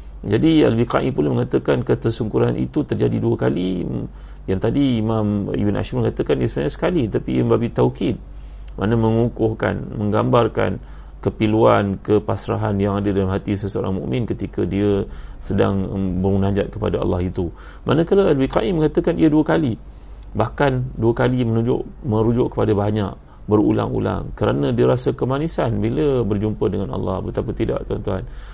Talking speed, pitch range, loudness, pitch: 135 wpm, 95-120 Hz, -20 LUFS, 105 Hz